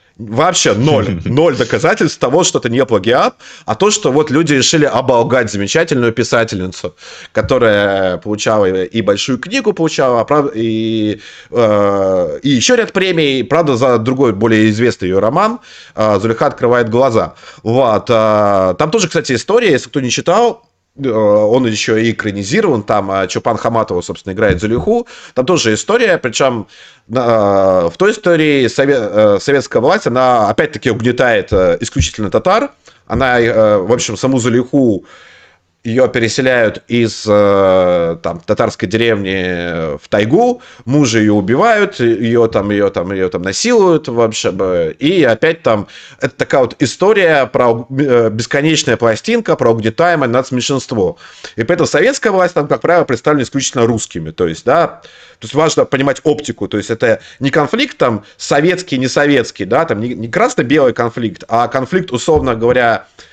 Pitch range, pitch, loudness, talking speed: 110-145 Hz, 120 Hz, -13 LUFS, 140 wpm